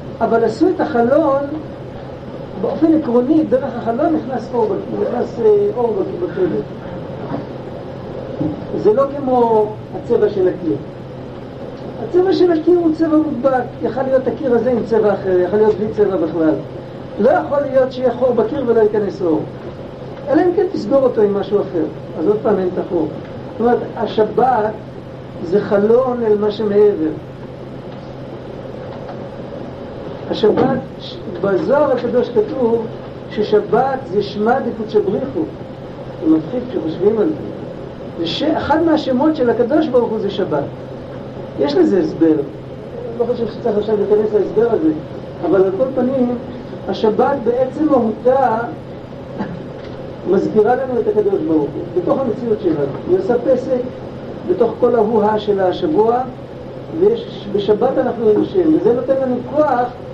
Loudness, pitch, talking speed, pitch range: -16 LUFS, 240 Hz, 135 wpm, 210-285 Hz